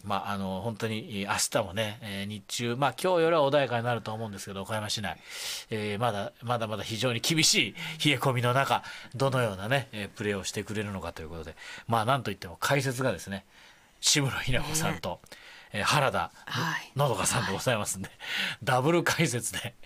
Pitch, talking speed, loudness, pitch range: 115 Hz, 375 characters per minute, -29 LUFS, 100-135 Hz